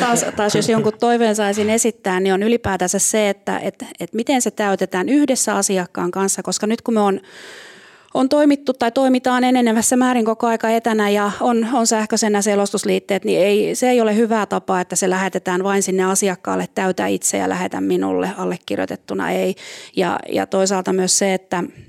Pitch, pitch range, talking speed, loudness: 205 Hz, 190-230 Hz, 180 wpm, -18 LUFS